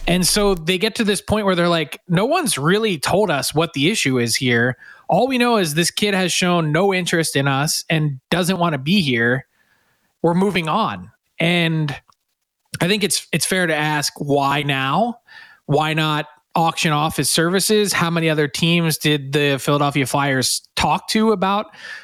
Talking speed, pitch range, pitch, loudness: 185 wpm, 145-195 Hz, 165 Hz, -18 LUFS